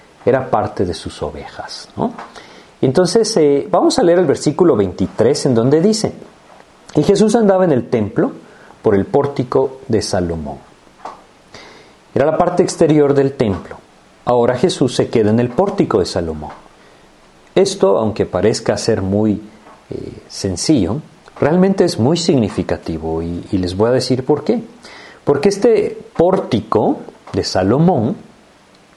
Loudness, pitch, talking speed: -15 LUFS, 135 Hz, 140 wpm